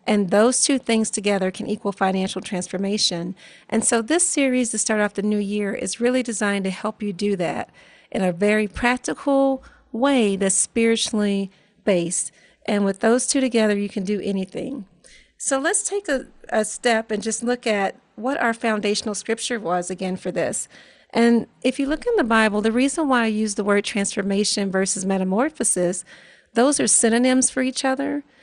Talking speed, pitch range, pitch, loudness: 180 wpm, 200-250 Hz, 215 Hz, -21 LUFS